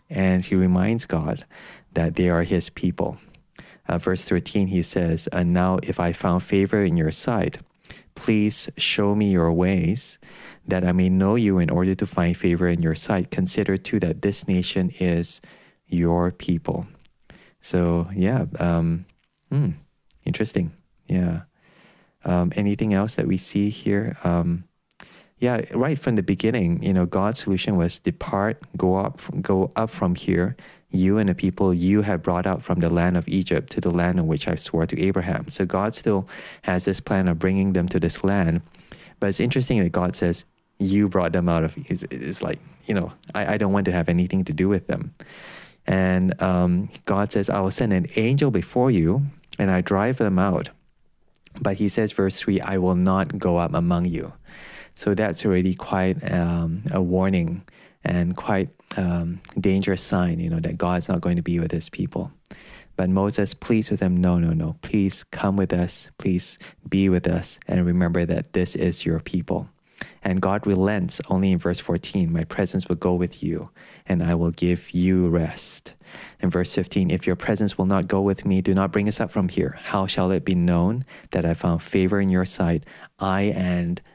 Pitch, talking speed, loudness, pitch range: 90 Hz, 190 wpm, -23 LUFS, 85-100 Hz